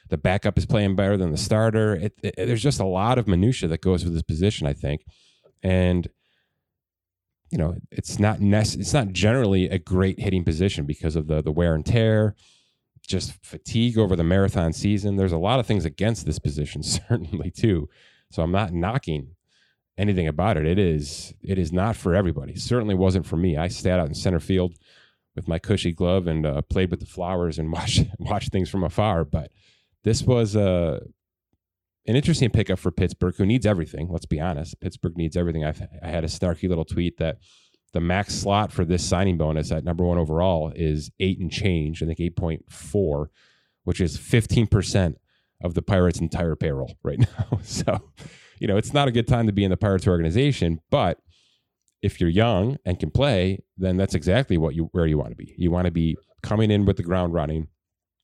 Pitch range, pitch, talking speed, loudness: 85-105 Hz, 90 Hz, 200 wpm, -23 LUFS